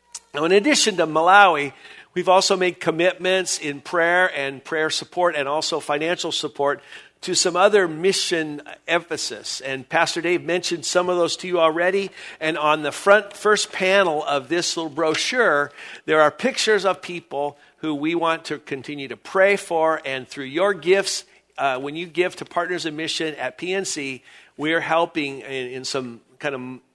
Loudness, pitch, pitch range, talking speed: -21 LUFS, 165 Hz, 150-185 Hz, 170 wpm